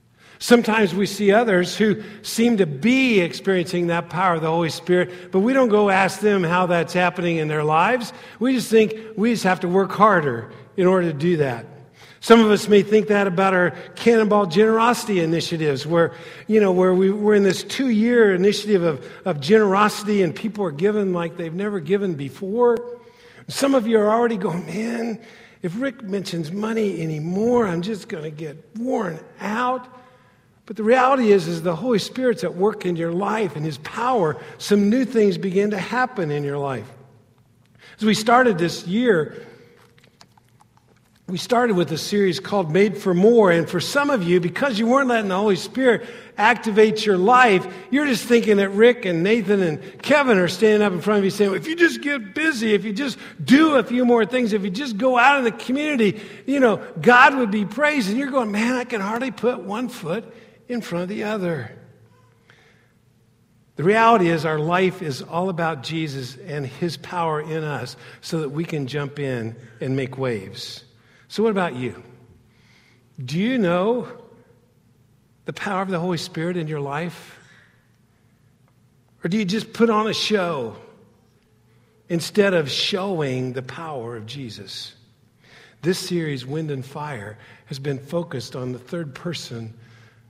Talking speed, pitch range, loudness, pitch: 180 wpm, 155-220 Hz, -20 LUFS, 190 Hz